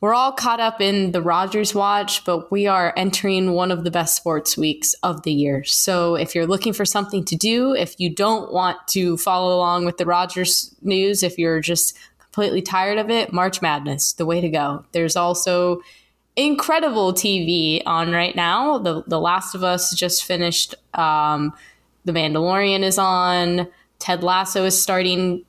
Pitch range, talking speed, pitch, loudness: 170-195 Hz, 175 wpm, 180 Hz, -19 LUFS